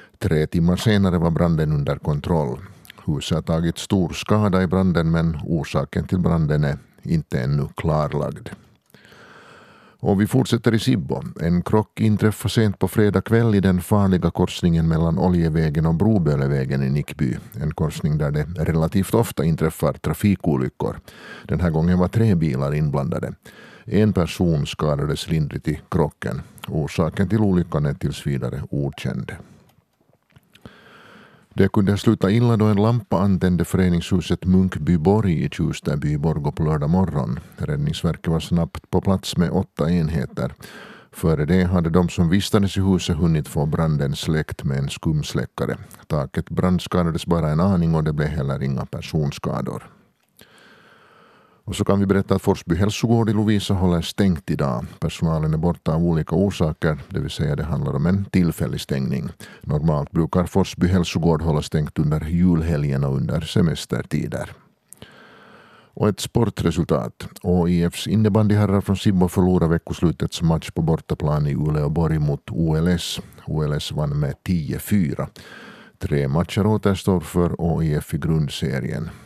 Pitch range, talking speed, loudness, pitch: 80-100 Hz, 145 wpm, -21 LUFS, 85 Hz